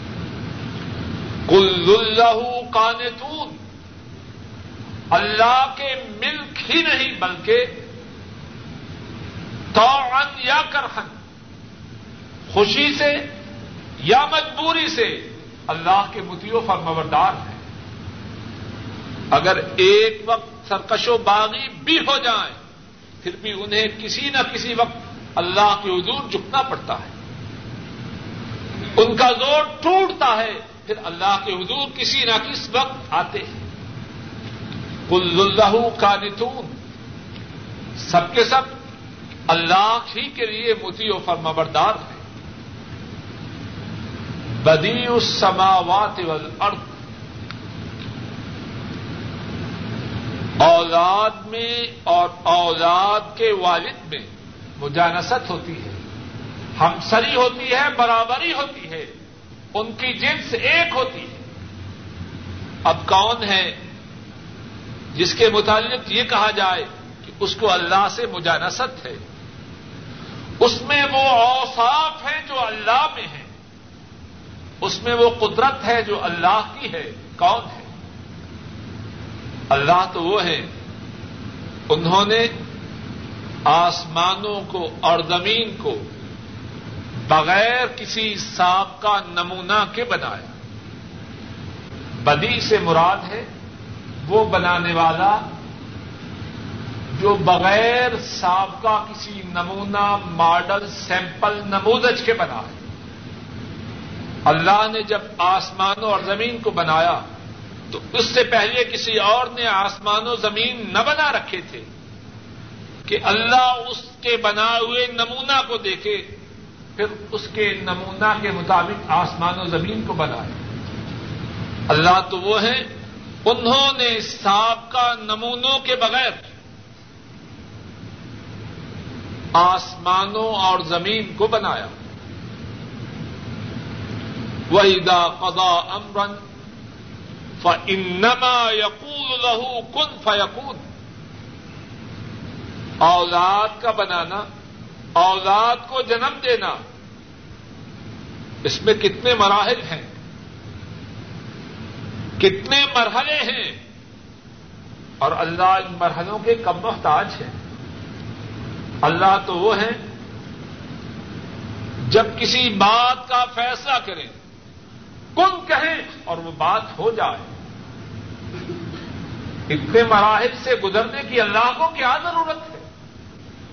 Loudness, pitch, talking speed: -18 LUFS, 200 Hz, 100 wpm